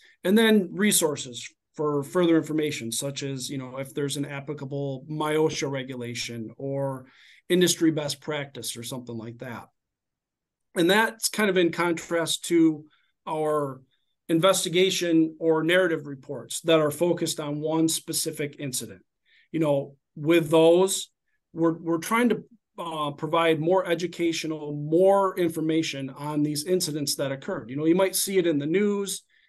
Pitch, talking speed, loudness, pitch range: 160 Hz, 145 wpm, -25 LUFS, 140-170 Hz